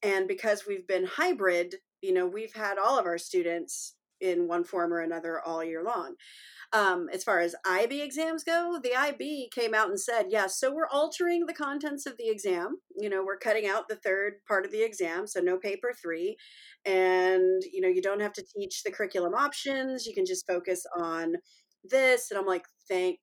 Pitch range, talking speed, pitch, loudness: 185-280 Hz, 205 wpm, 200 Hz, -30 LUFS